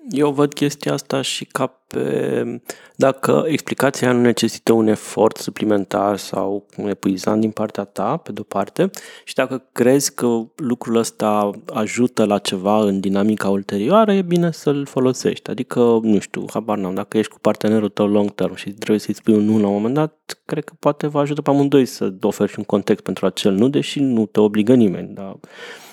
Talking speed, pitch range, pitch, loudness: 190 wpm, 100-130 Hz, 110 Hz, -19 LUFS